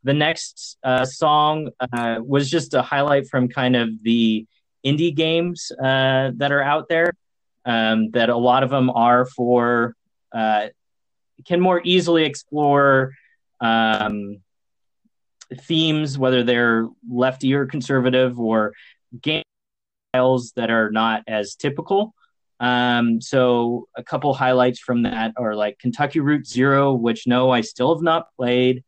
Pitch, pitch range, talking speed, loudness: 125 Hz, 115-145 Hz, 135 wpm, -19 LUFS